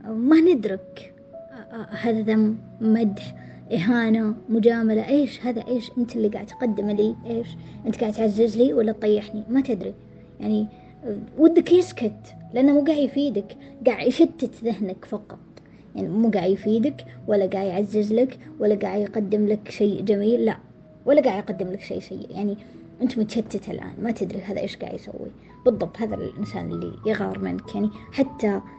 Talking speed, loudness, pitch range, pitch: 155 wpm, -23 LUFS, 205-240 Hz, 220 Hz